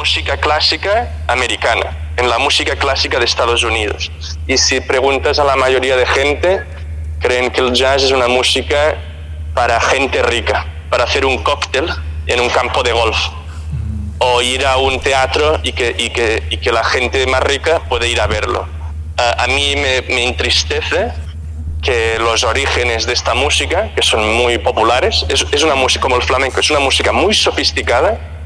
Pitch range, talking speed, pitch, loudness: 80-115 Hz, 175 wpm, 80 Hz, -13 LUFS